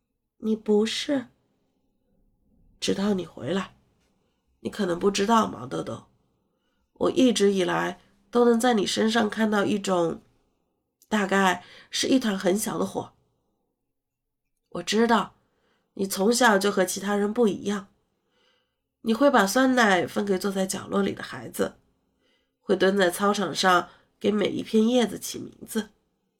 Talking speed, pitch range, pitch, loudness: 195 characters per minute, 190-225 Hz, 205 Hz, -24 LUFS